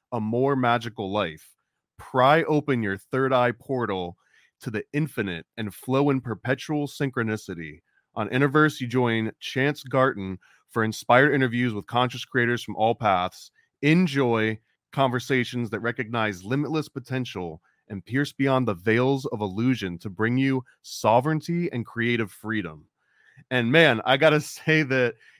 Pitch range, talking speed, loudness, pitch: 110-135 Hz, 140 wpm, -24 LUFS, 125 Hz